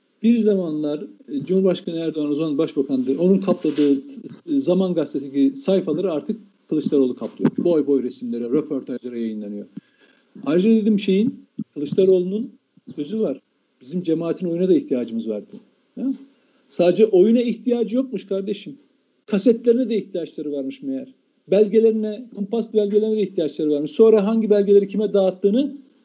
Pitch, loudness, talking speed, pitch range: 195 Hz, -20 LUFS, 125 wpm, 150-225 Hz